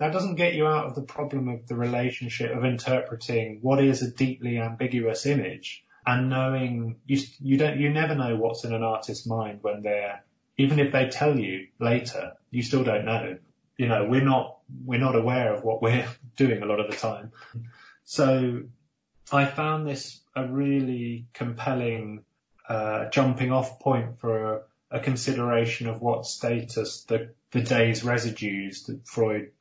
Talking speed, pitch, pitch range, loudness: 170 wpm, 125 Hz, 115-135 Hz, -26 LUFS